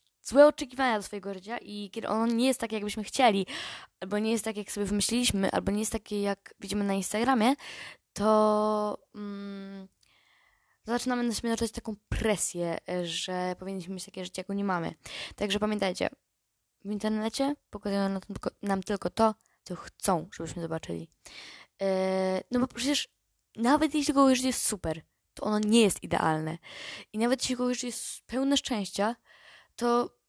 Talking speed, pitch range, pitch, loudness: 155 wpm, 195-235 Hz, 210 Hz, -29 LUFS